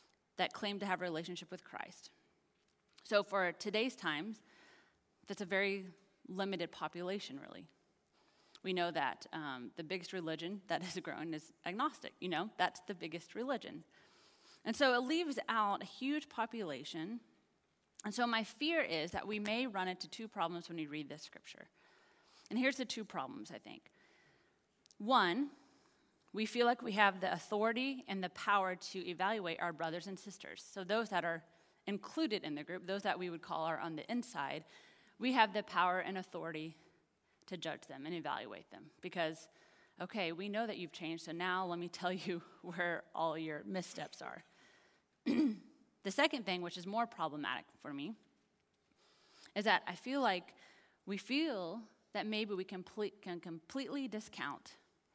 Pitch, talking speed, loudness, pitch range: 195 Hz, 170 wpm, -39 LUFS, 175-230 Hz